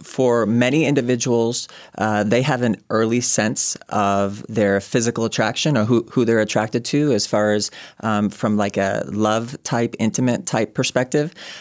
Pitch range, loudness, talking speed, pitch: 105-125 Hz, -19 LUFS, 160 wpm, 115 Hz